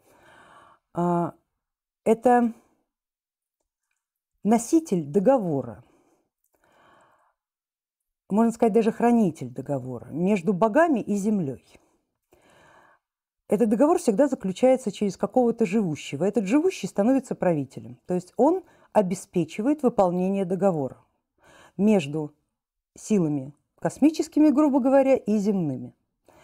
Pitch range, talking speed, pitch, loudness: 160-240 Hz, 85 wpm, 205 Hz, -24 LUFS